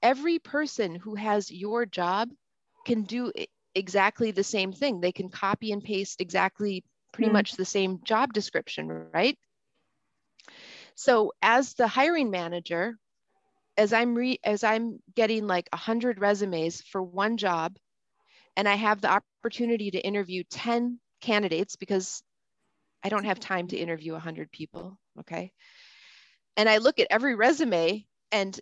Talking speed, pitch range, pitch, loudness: 145 wpm, 190-240 Hz, 210 Hz, -27 LUFS